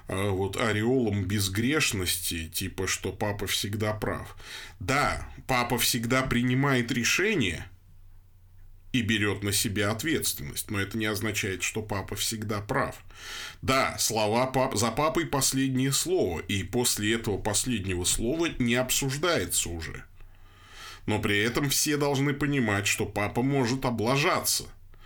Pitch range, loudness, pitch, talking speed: 95-125 Hz, -27 LUFS, 110 Hz, 120 wpm